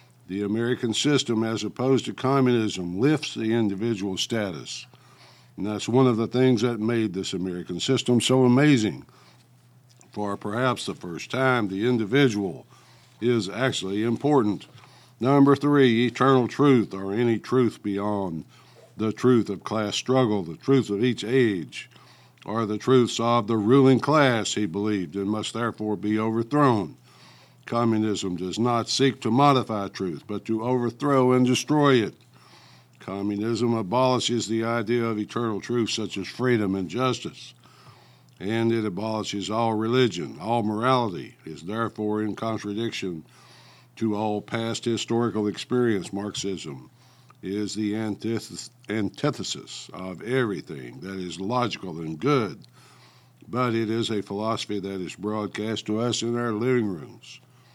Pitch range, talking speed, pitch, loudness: 105-125 Hz, 140 wpm, 115 Hz, -24 LUFS